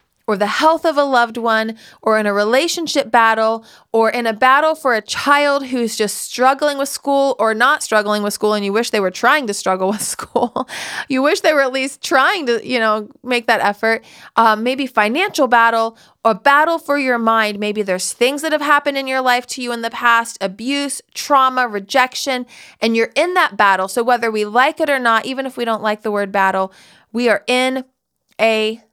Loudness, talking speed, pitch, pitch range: -16 LUFS, 210 wpm, 240 Hz, 220-275 Hz